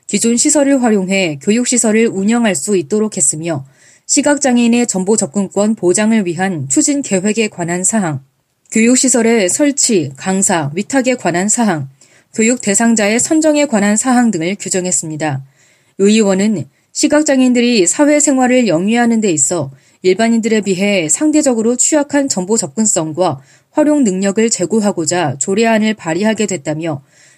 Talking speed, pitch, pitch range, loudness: 325 characters per minute, 205 Hz, 175-240 Hz, -13 LUFS